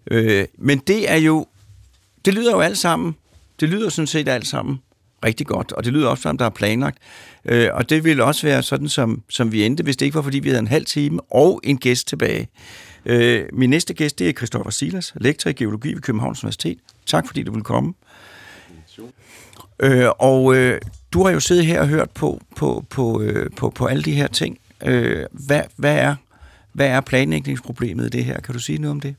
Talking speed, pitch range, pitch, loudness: 205 wpm, 110-145 Hz, 130 Hz, -19 LUFS